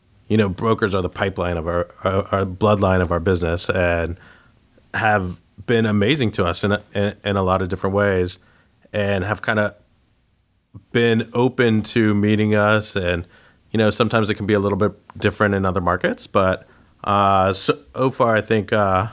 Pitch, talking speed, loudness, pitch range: 100 Hz, 175 wpm, -20 LUFS, 95-110 Hz